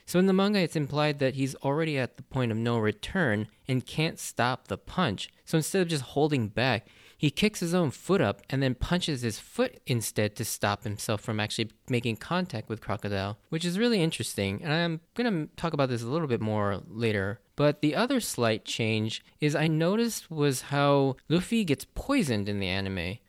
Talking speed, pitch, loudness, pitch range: 205 wpm, 135 Hz, -29 LUFS, 110-160 Hz